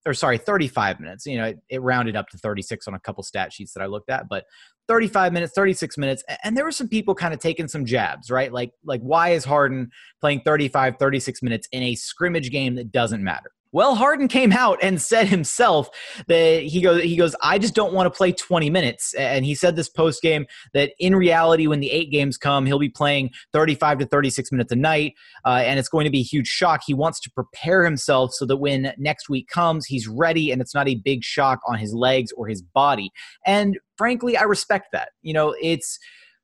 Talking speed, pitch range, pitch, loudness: 225 wpm, 130-175 Hz, 150 Hz, -21 LUFS